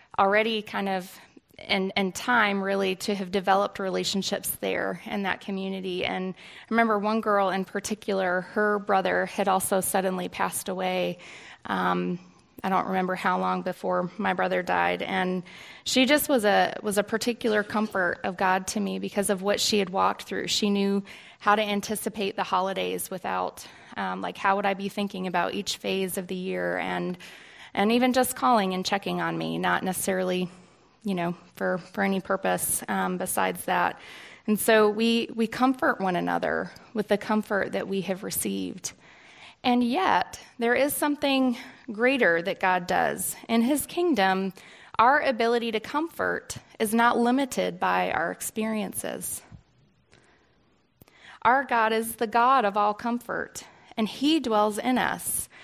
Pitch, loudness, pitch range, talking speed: 200 Hz, -26 LUFS, 185-225 Hz, 160 wpm